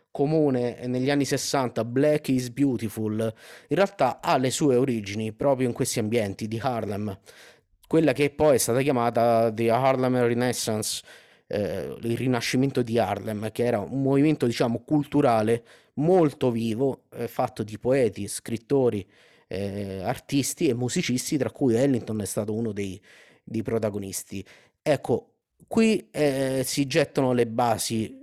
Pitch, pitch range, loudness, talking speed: 125 Hz, 110-140 Hz, -25 LUFS, 140 wpm